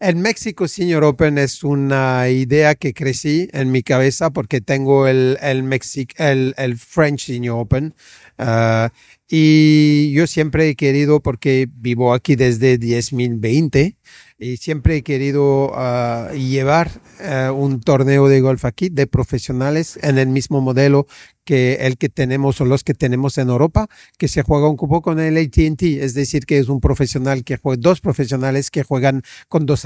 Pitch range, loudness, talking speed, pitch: 130-150 Hz, -16 LUFS, 165 wpm, 140 Hz